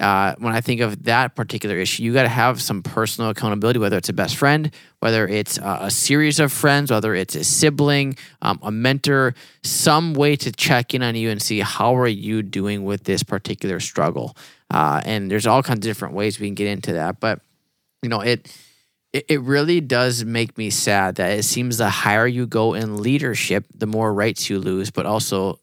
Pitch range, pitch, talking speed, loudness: 105-135 Hz, 115 Hz, 215 wpm, -20 LUFS